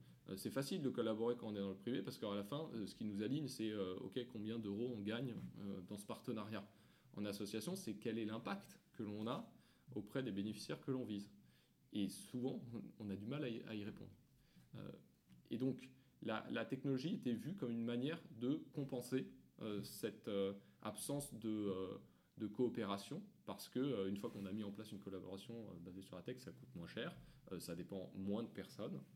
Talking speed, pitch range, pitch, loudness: 185 wpm, 100-120 Hz, 110 Hz, -47 LUFS